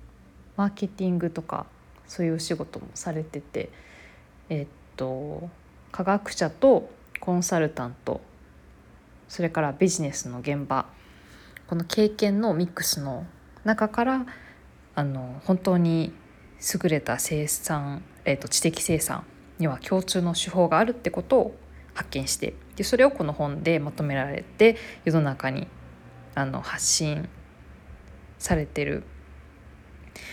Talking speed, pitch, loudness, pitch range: 240 characters per minute, 160 Hz, -26 LUFS, 130-185 Hz